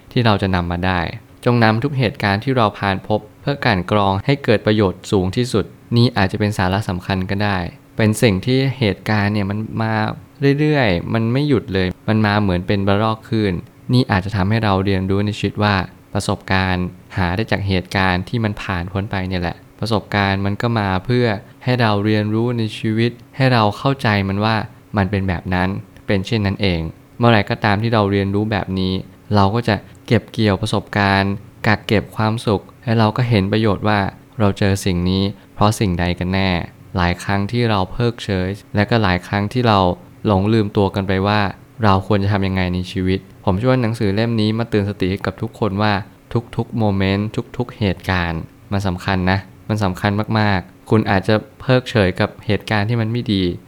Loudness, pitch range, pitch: -18 LUFS, 95-115 Hz, 105 Hz